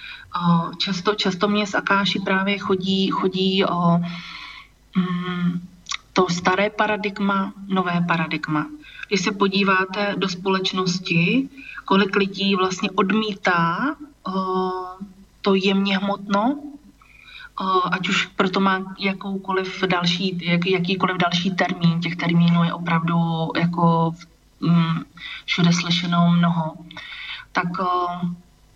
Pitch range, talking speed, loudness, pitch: 175-200 Hz, 100 wpm, -21 LUFS, 190 Hz